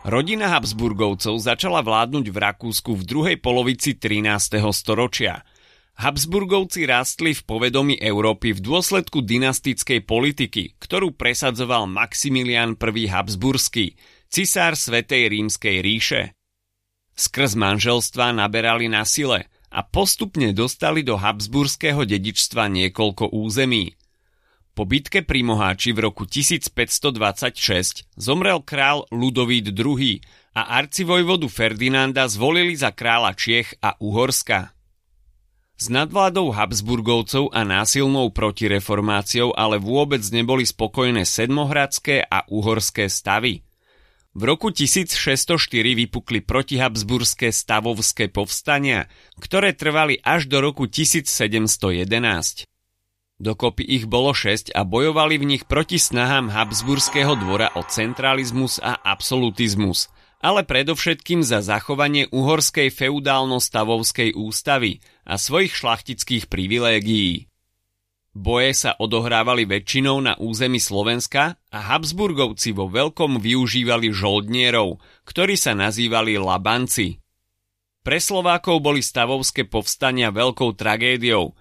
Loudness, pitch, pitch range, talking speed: -19 LUFS, 120 Hz, 105-140 Hz, 105 wpm